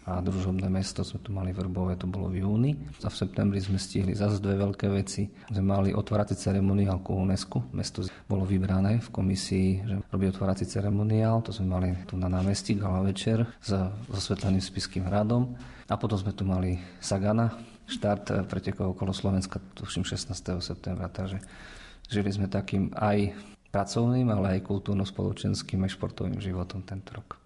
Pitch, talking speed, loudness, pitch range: 100 Hz, 160 wpm, -29 LUFS, 95-105 Hz